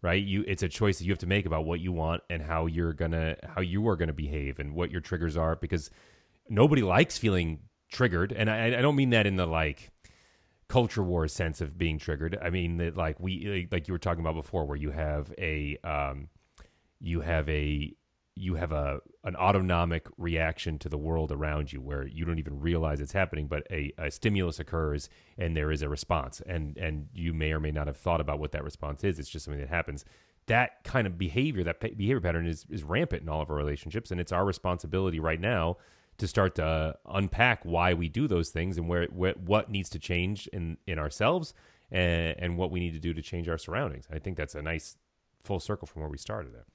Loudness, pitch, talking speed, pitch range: -31 LUFS, 85 Hz, 225 wpm, 75-95 Hz